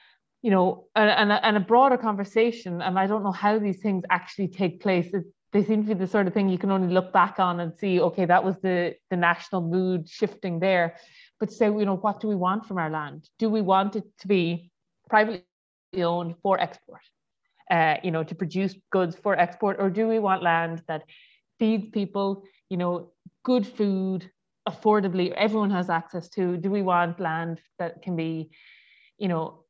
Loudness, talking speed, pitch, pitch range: -25 LUFS, 200 wpm, 190 Hz, 175-205 Hz